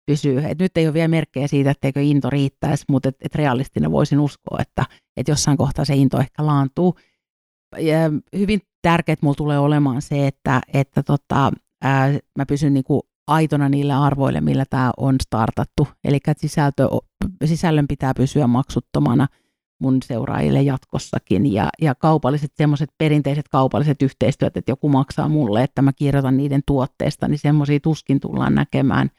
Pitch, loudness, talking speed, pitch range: 140 Hz, -19 LUFS, 150 wpm, 135-150 Hz